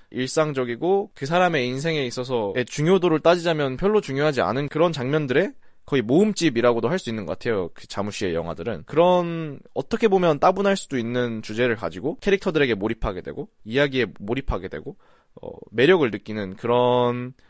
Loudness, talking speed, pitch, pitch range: -22 LUFS, 395 characters per minute, 140 Hz, 120-170 Hz